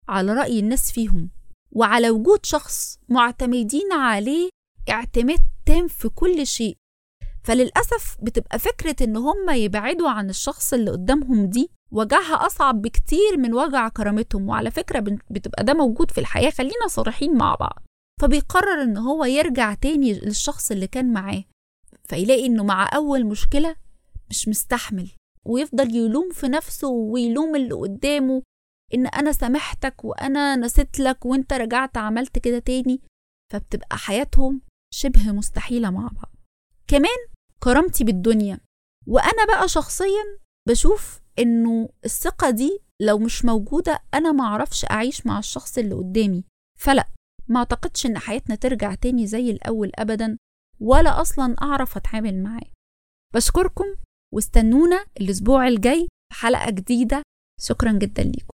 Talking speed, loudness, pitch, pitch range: 130 wpm, -21 LUFS, 255 Hz, 225-290 Hz